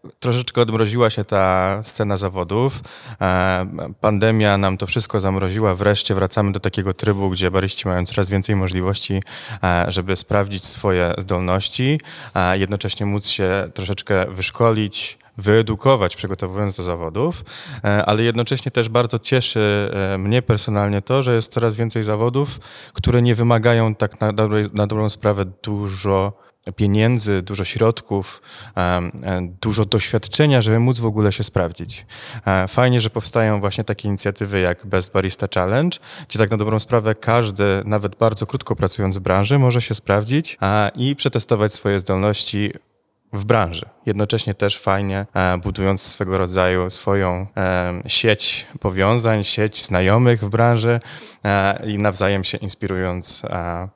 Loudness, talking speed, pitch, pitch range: -19 LUFS, 130 wpm, 105 Hz, 95-115 Hz